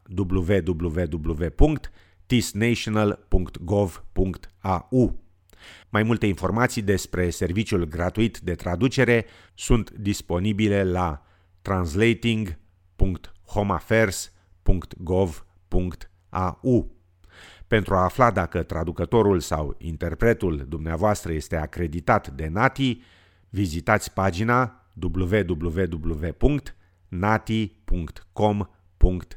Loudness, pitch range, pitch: -24 LUFS, 85-105 Hz, 95 Hz